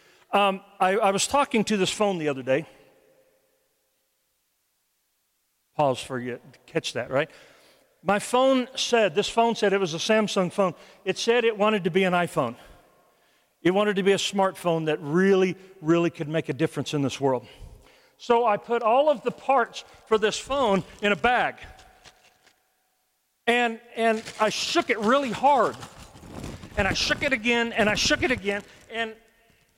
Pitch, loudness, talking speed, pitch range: 205 Hz, -24 LUFS, 170 wpm, 185-235 Hz